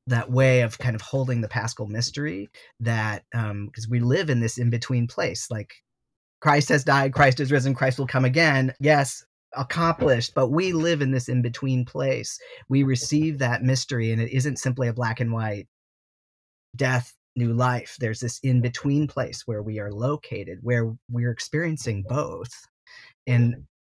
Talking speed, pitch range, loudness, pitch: 175 wpm, 115-140 Hz, -24 LUFS, 125 Hz